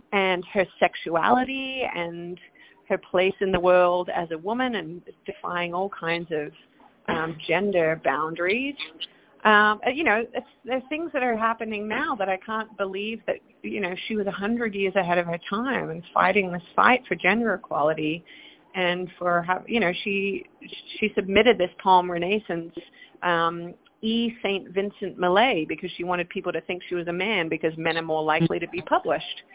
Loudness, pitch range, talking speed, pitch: -24 LUFS, 175-215 Hz, 175 wpm, 190 Hz